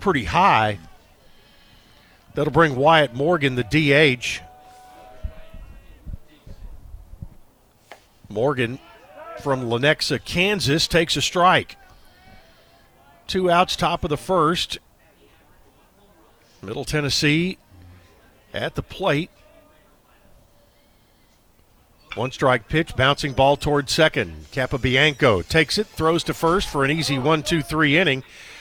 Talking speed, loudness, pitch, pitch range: 95 wpm, -20 LUFS, 140 Hz, 105-160 Hz